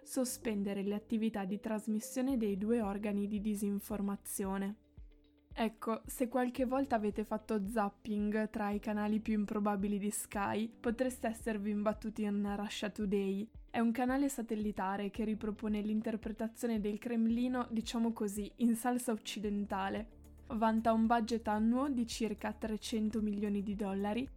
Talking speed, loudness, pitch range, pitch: 135 wpm, -36 LUFS, 205-230 Hz, 215 Hz